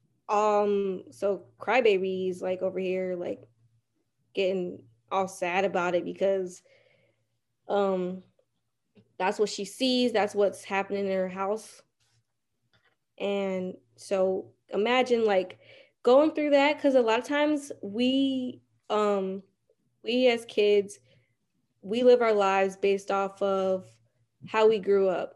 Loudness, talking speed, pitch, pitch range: -27 LUFS, 125 wpm, 195 Hz, 180-210 Hz